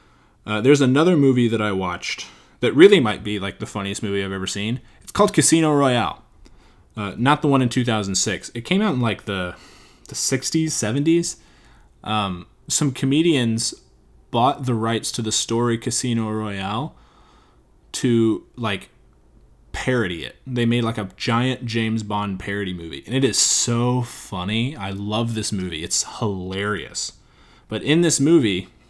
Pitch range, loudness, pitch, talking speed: 100-130 Hz, -21 LUFS, 110 Hz, 160 wpm